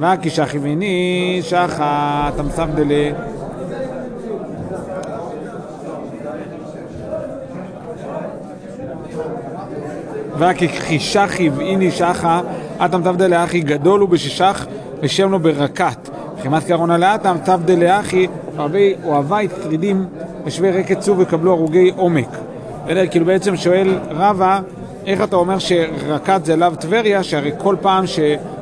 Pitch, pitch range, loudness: 175 Hz, 160-190 Hz, -17 LUFS